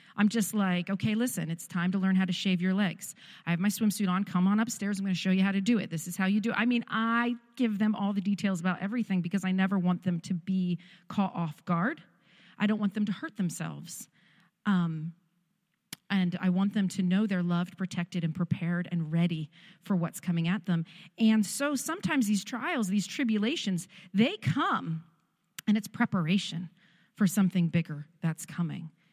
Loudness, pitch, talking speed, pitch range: -30 LUFS, 190 Hz, 205 wpm, 175-205 Hz